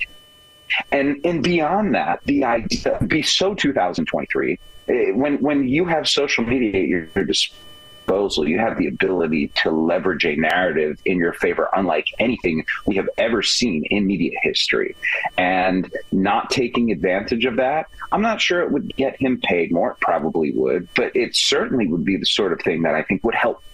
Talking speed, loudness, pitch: 180 wpm, -20 LUFS, 145 Hz